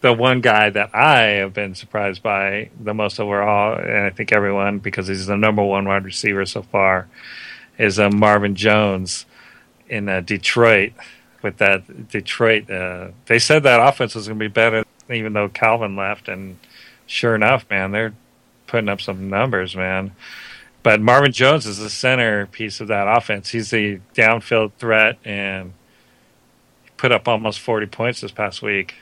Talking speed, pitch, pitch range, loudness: 165 wpm, 105 Hz, 100-115 Hz, -17 LUFS